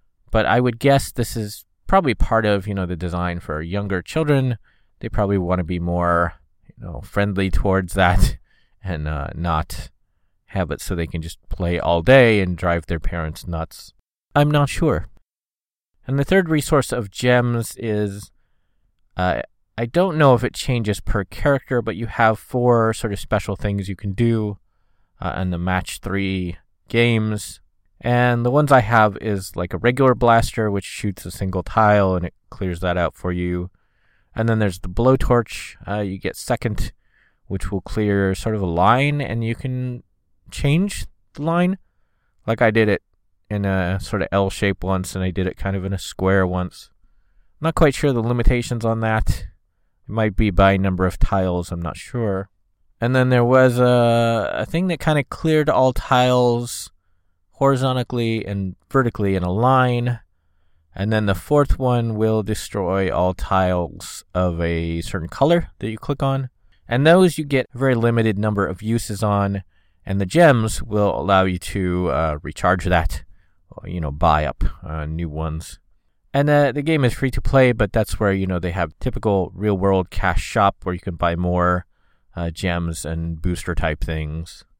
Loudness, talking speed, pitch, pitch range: -20 LUFS, 180 wpm, 100 Hz, 90-120 Hz